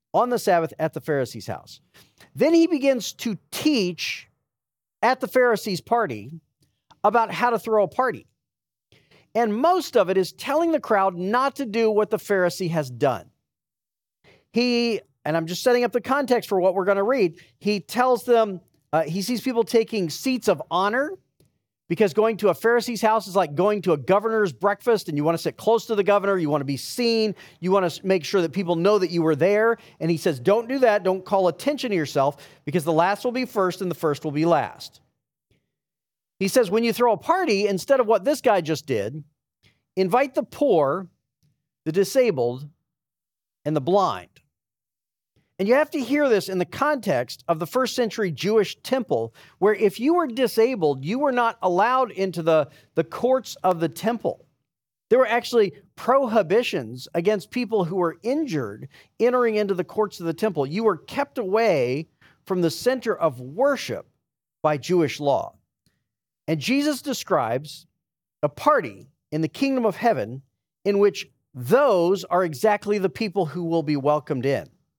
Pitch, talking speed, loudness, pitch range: 200 Hz, 180 wpm, -23 LUFS, 165-235 Hz